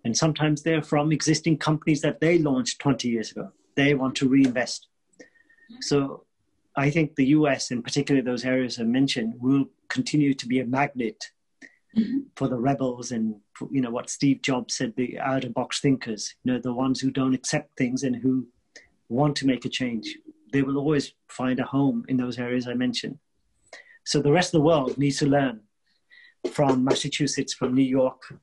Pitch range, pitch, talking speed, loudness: 125-150 Hz, 135 Hz, 185 wpm, -25 LUFS